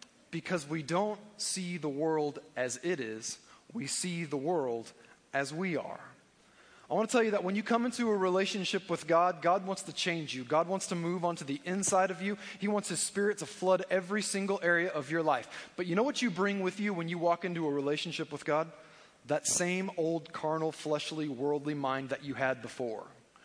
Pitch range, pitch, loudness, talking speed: 150-195 Hz, 175 Hz, -33 LUFS, 210 wpm